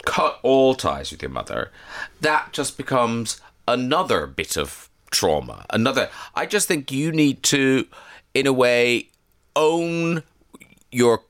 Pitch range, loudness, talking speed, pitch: 125-155 Hz, -21 LUFS, 135 wpm, 135 Hz